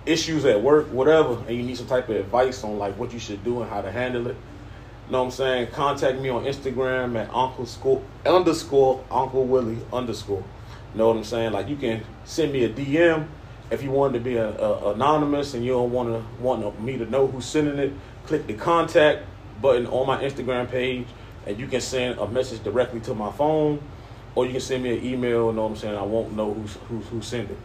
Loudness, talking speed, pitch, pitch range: -24 LUFS, 230 wpm, 125 Hz, 115-130 Hz